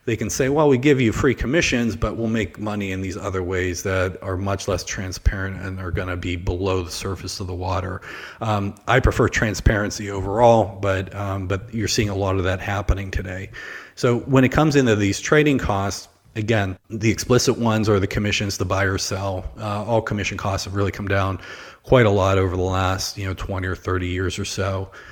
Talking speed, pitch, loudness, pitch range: 215 wpm, 100 Hz, -21 LUFS, 95-110 Hz